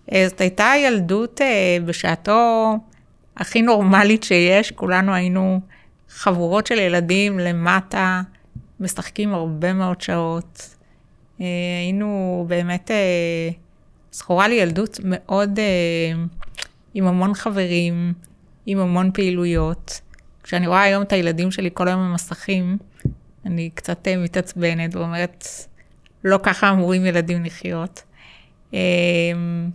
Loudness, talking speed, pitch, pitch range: -19 LUFS, 95 wpm, 185 Hz, 175-195 Hz